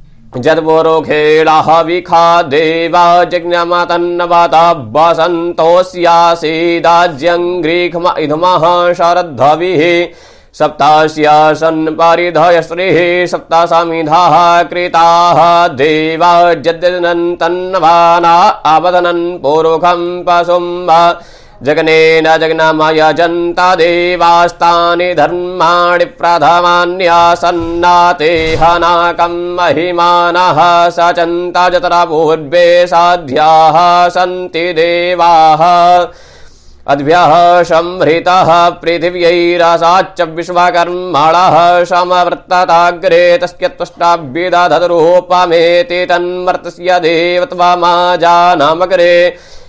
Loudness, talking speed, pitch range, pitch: -8 LUFS, 55 wpm, 165-175 Hz, 175 Hz